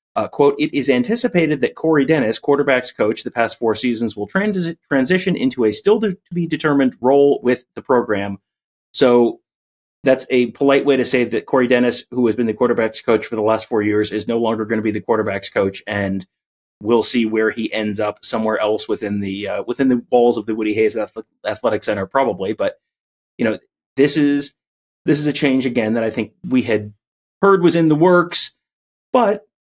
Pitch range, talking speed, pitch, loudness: 110-145 Hz, 205 wpm, 125 Hz, -18 LUFS